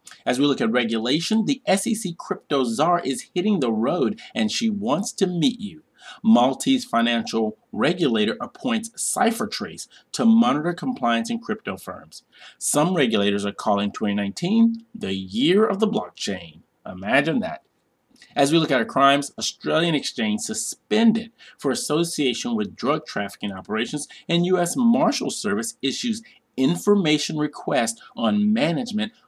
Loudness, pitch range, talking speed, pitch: -22 LUFS, 140-230 Hz, 135 wpm, 205 Hz